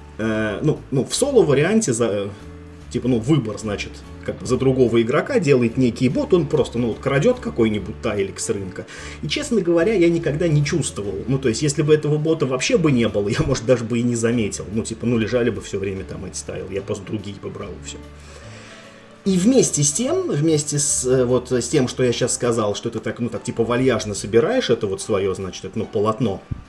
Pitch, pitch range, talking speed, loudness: 120 Hz, 105-140 Hz, 210 wpm, -20 LUFS